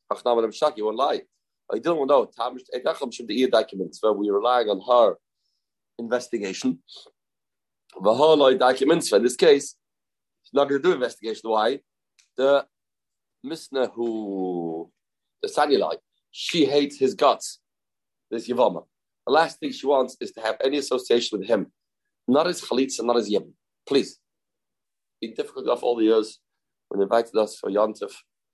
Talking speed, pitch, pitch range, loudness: 135 wpm, 115 Hz, 105-140 Hz, -23 LUFS